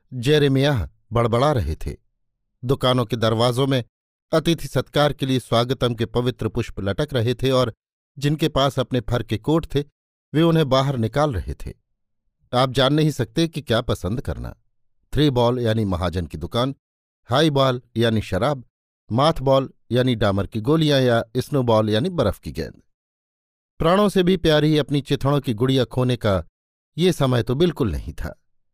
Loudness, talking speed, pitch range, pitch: -21 LUFS, 165 wpm, 110-140 Hz, 125 Hz